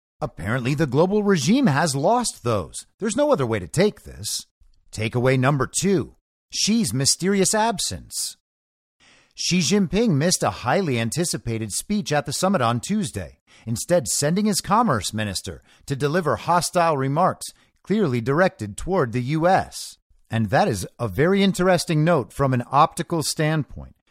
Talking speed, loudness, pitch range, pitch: 140 wpm, -21 LUFS, 110-185 Hz, 145 Hz